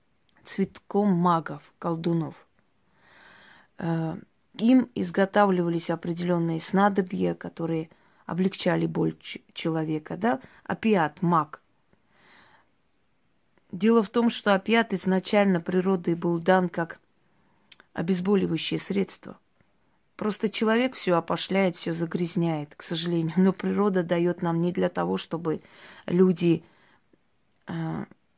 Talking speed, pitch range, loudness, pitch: 90 wpm, 165-195 Hz, -26 LUFS, 180 Hz